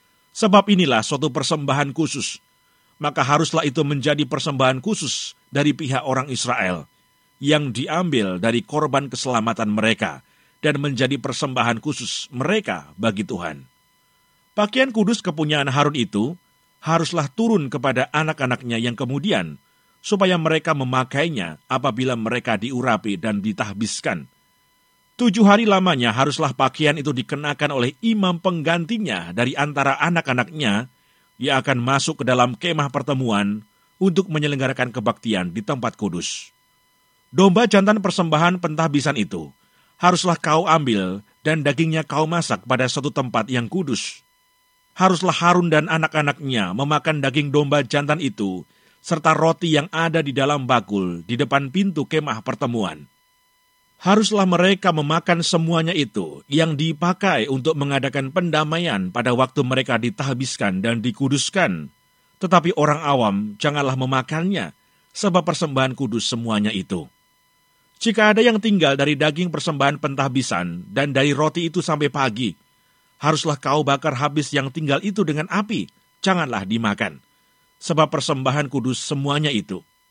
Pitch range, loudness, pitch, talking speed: 130-165 Hz, -20 LUFS, 145 Hz, 125 wpm